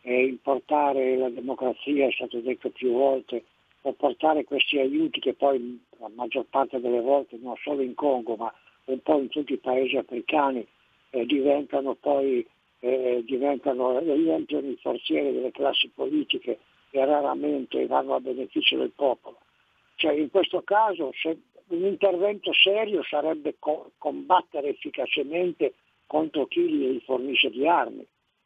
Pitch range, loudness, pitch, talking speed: 130-160 Hz, -26 LUFS, 140 Hz, 140 wpm